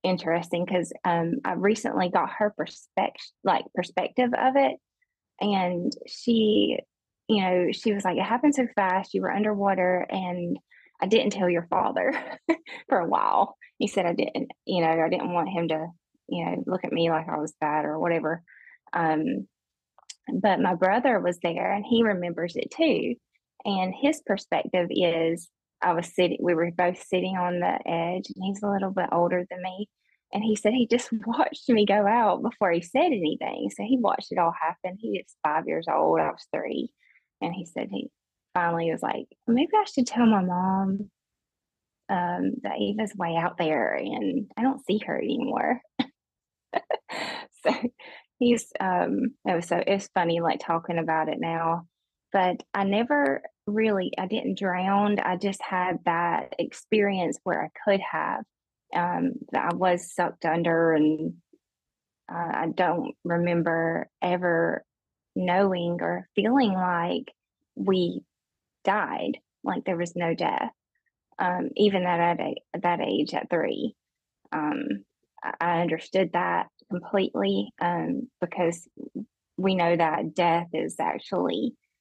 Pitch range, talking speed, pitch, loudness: 170-215 Hz, 155 wpm, 185 Hz, -26 LUFS